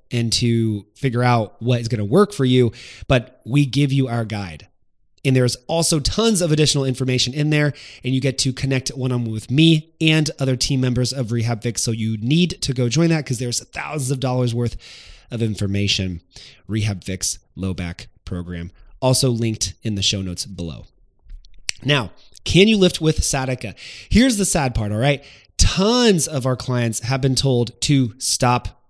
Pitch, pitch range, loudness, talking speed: 125 Hz, 110-140 Hz, -19 LUFS, 185 wpm